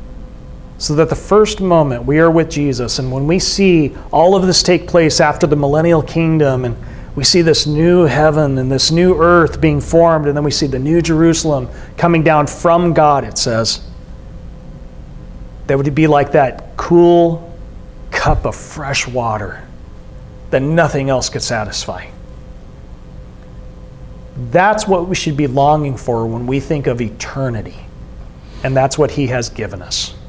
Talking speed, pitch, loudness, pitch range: 160 wpm, 145 Hz, -13 LUFS, 125-165 Hz